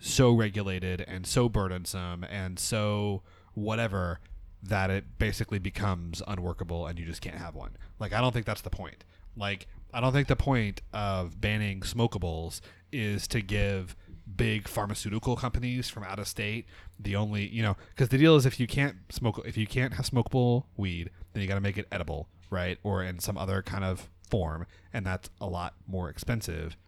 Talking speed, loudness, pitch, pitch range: 190 wpm, -31 LUFS, 100 Hz, 90-110 Hz